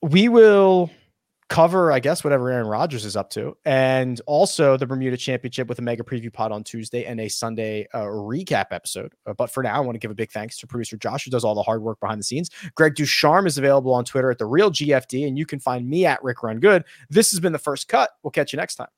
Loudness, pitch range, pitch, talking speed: -21 LUFS, 115-155 Hz, 130 Hz, 260 wpm